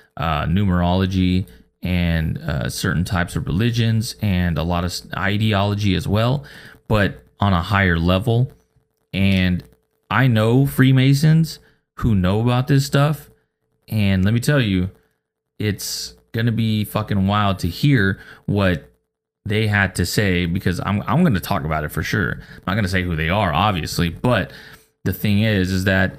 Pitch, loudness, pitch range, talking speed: 100 Hz, -19 LUFS, 90-115 Hz, 165 wpm